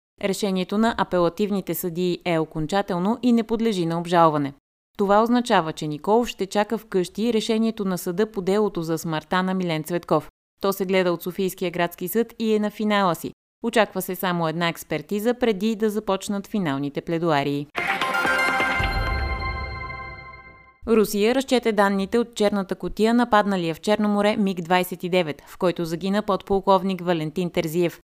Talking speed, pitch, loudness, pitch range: 145 wpm, 185 Hz, -23 LUFS, 170-210 Hz